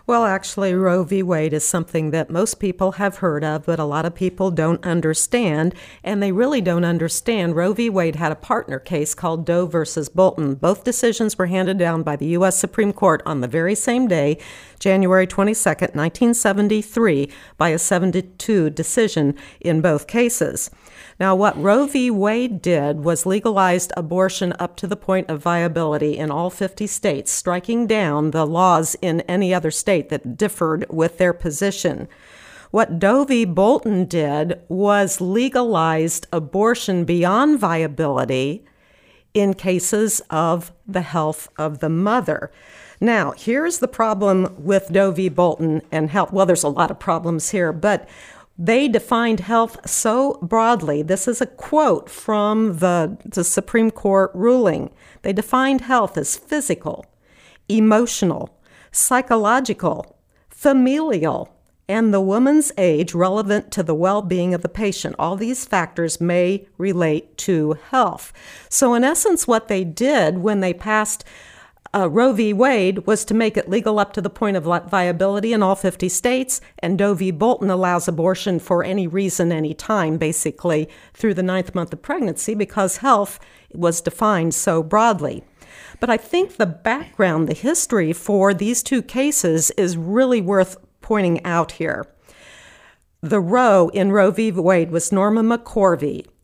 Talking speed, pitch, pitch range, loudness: 155 wpm, 190 Hz, 170-215 Hz, -19 LUFS